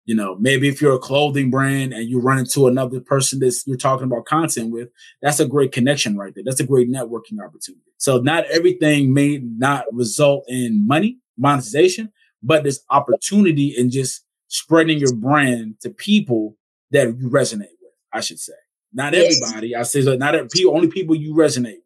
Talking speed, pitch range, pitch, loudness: 190 wpm, 125-155 Hz, 140 Hz, -18 LUFS